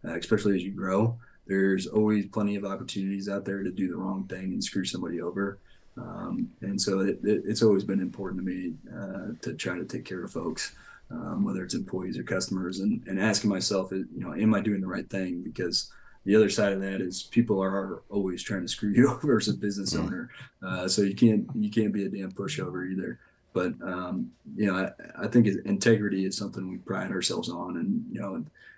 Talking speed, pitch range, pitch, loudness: 220 wpm, 95-110 Hz, 100 Hz, -29 LUFS